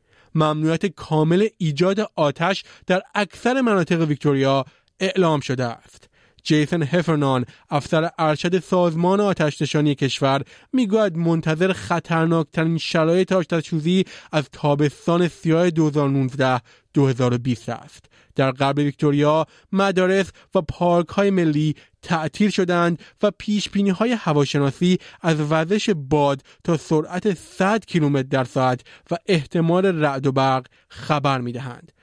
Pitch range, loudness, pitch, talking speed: 145-185 Hz, -21 LUFS, 160 Hz, 110 wpm